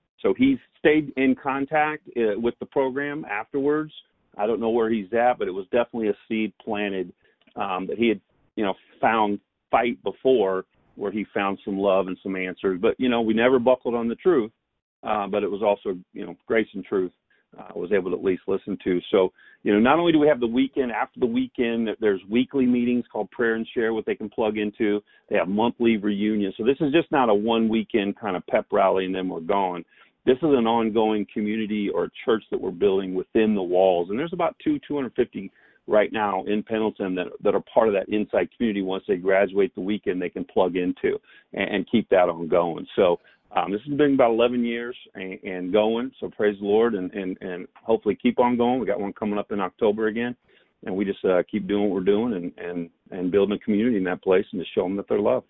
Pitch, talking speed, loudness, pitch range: 110 Hz, 230 wpm, -24 LUFS, 100-125 Hz